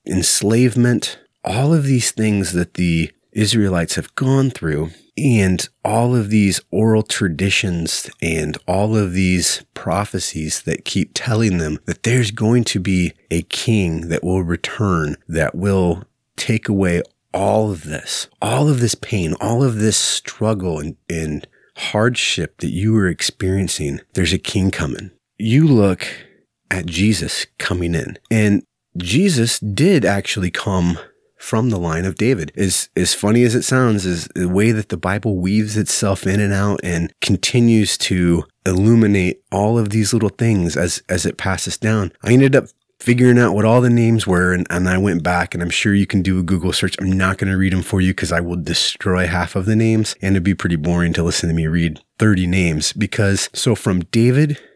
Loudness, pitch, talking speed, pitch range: -17 LUFS, 95 Hz, 180 wpm, 90-110 Hz